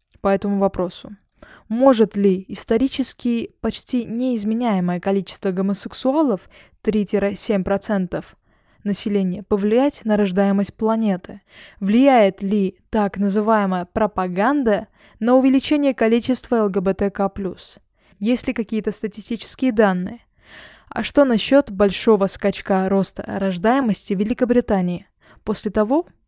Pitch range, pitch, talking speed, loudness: 195-235 Hz, 210 Hz, 95 wpm, -20 LUFS